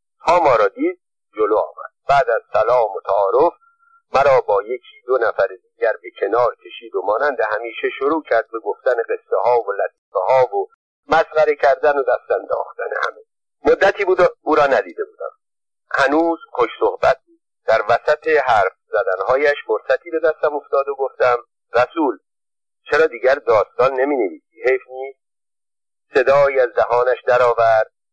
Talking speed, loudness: 155 wpm, -18 LUFS